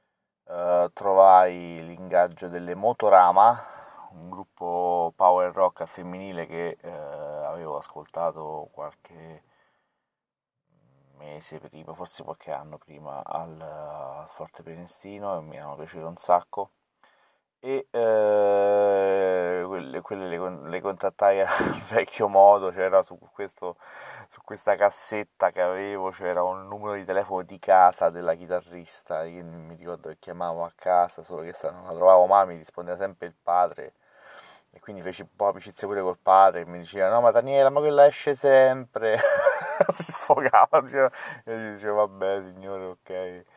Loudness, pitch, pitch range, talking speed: -23 LUFS, 95 Hz, 85-100 Hz, 145 wpm